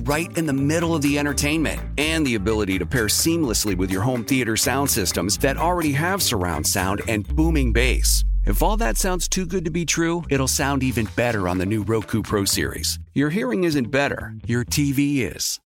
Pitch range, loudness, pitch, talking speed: 100-150 Hz, -21 LUFS, 125 Hz, 205 wpm